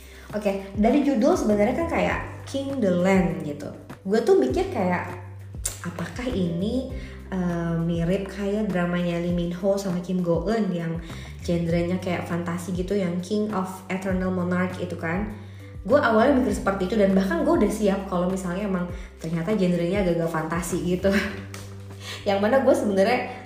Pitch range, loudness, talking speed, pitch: 170-200 Hz, -24 LUFS, 160 wpm, 180 Hz